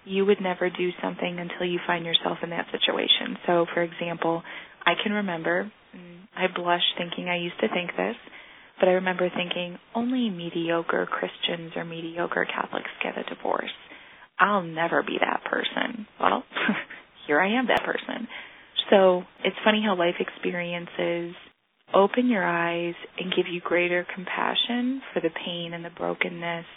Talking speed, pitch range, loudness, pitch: 155 wpm, 170-195 Hz, -26 LUFS, 175 Hz